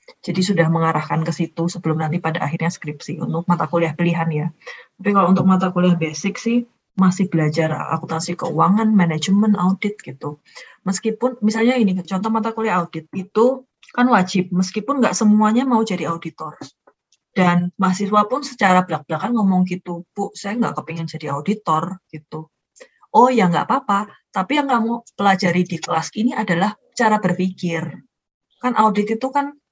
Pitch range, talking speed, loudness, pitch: 165-220 Hz, 155 wpm, -19 LUFS, 190 Hz